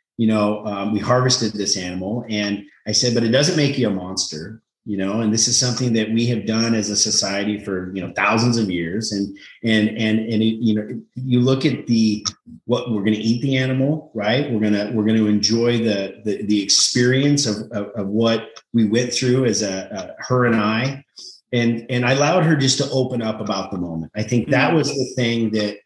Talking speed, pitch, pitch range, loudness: 225 wpm, 110 Hz, 105-125 Hz, -19 LUFS